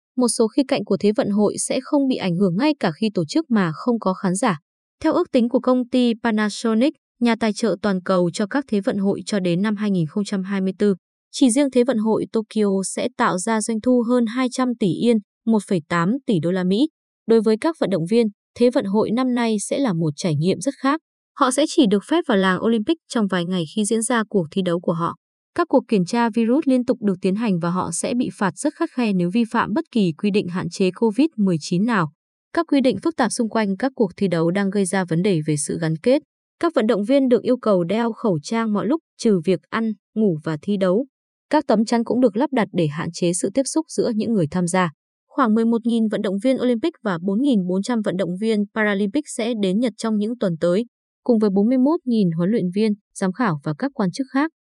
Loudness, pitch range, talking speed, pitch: -21 LUFS, 195-255 Hz, 240 wpm, 220 Hz